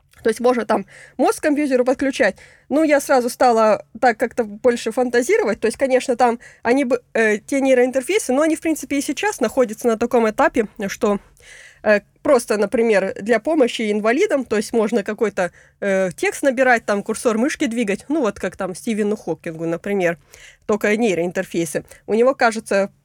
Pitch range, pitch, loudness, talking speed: 210-265 Hz, 235 Hz, -19 LUFS, 165 wpm